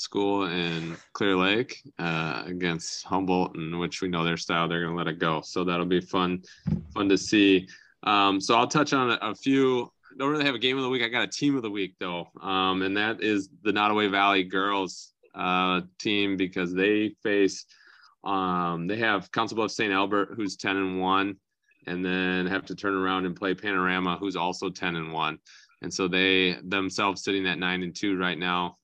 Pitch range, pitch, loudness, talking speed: 90-100 Hz, 95 Hz, -26 LUFS, 210 wpm